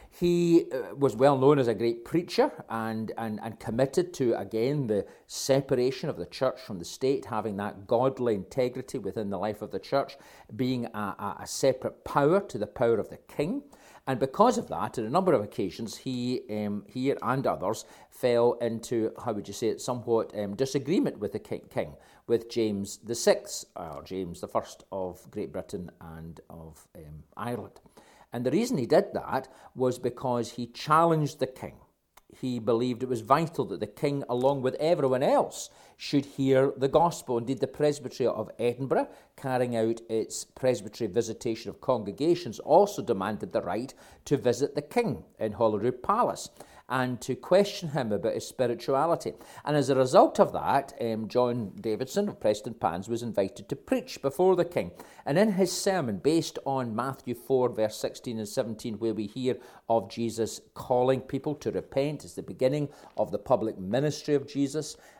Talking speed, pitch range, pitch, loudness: 180 wpm, 110-140 Hz, 125 Hz, -29 LUFS